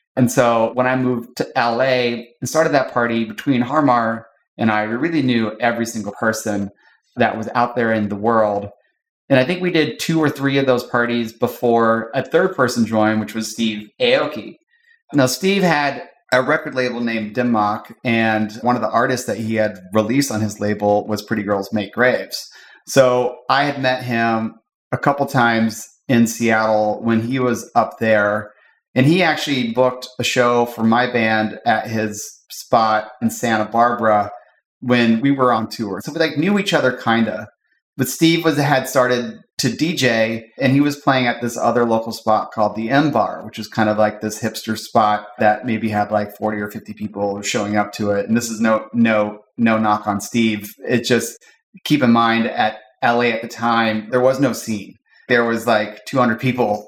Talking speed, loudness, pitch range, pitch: 195 wpm, -18 LUFS, 110-125 Hz, 115 Hz